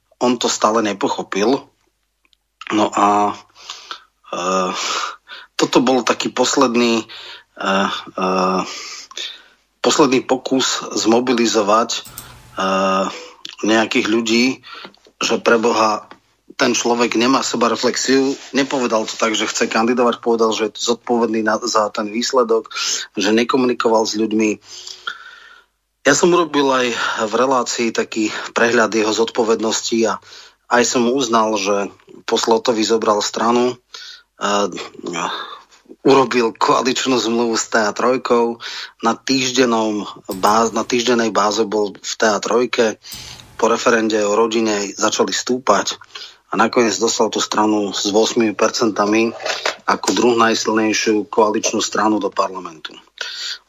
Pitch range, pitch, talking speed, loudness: 110-125 Hz, 115 Hz, 110 wpm, -17 LUFS